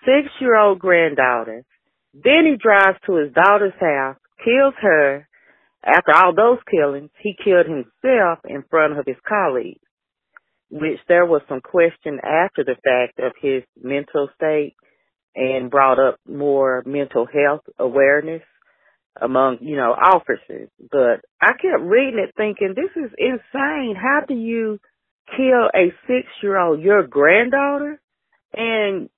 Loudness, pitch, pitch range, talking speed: -17 LUFS, 175 Hz, 140-230 Hz, 140 wpm